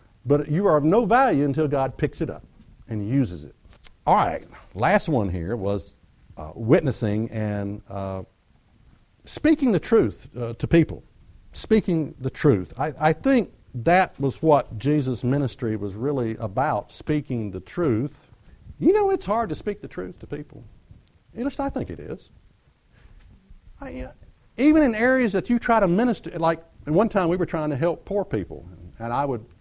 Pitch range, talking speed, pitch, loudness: 110-175 Hz, 175 wpm, 140 Hz, -23 LUFS